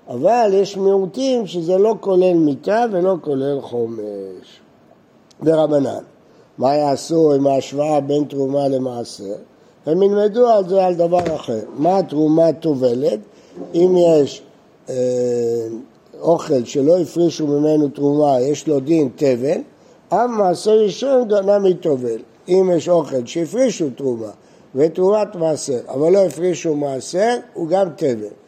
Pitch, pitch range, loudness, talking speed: 155 Hz, 135-185 Hz, -17 LUFS, 125 wpm